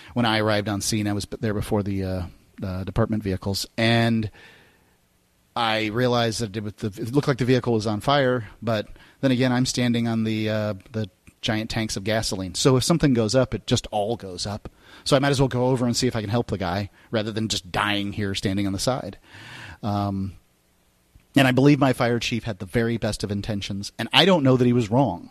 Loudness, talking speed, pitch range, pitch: -23 LUFS, 225 wpm, 100-125 Hz, 110 Hz